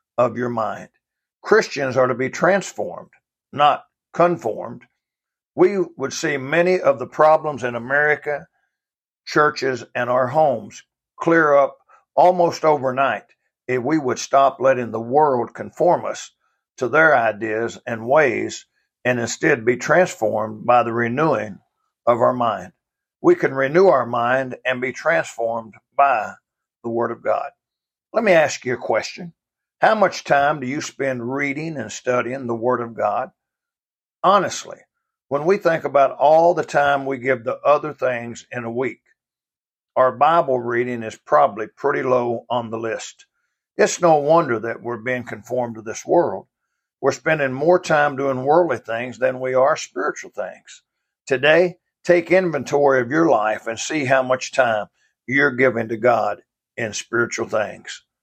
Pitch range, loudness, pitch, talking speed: 120-155 Hz, -19 LUFS, 130 Hz, 155 wpm